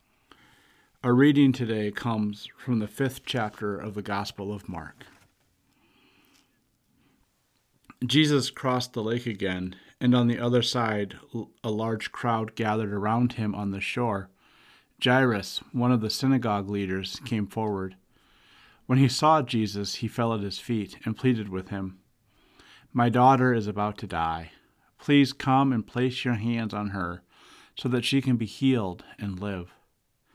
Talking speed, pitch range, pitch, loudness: 150 wpm, 100-125 Hz, 110 Hz, -26 LUFS